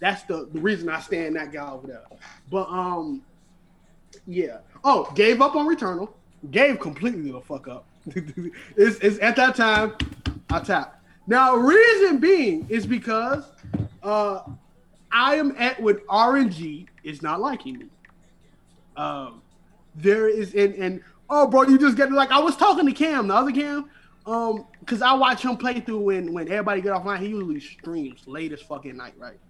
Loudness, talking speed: -21 LUFS, 170 wpm